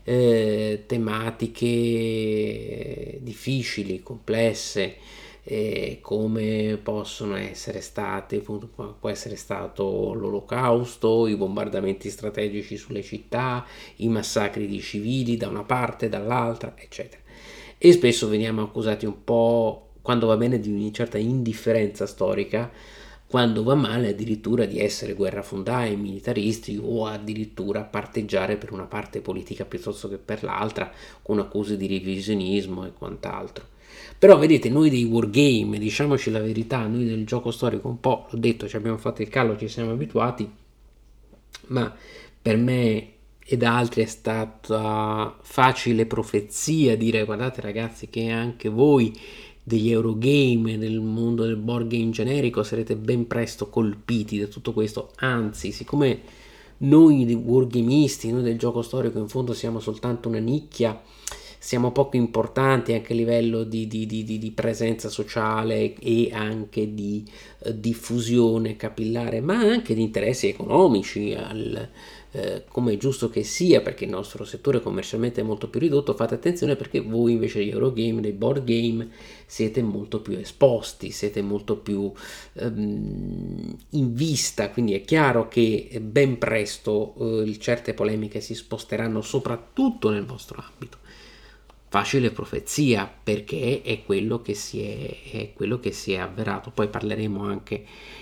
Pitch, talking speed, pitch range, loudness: 115 Hz, 135 wpm, 105-120 Hz, -24 LUFS